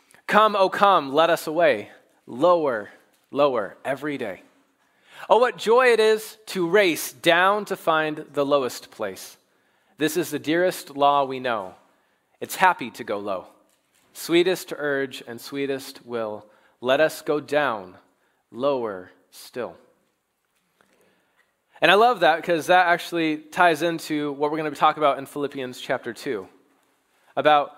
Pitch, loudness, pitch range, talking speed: 155 Hz, -22 LUFS, 140-180 Hz, 145 wpm